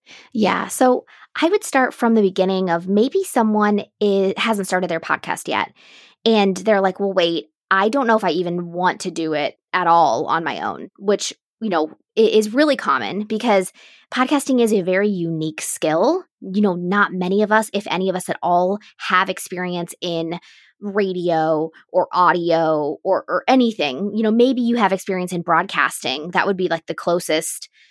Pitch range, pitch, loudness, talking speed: 175-220 Hz, 195 Hz, -19 LUFS, 185 wpm